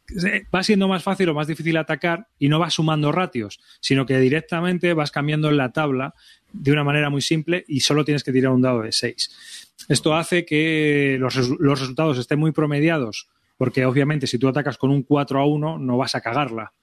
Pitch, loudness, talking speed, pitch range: 145 Hz, -21 LUFS, 205 wpm, 130-160 Hz